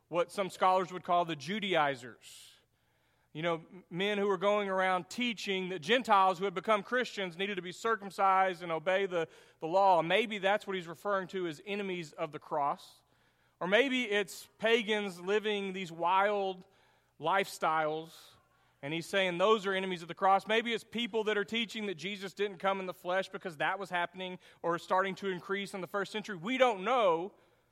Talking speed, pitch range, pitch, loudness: 190 wpm, 175-205 Hz, 190 Hz, -32 LUFS